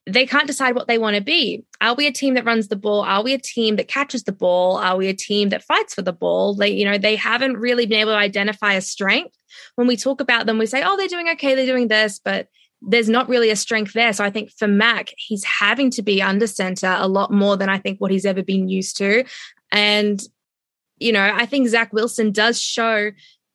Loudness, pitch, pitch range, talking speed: -18 LUFS, 220 Hz, 200-245 Hz, 250 wpm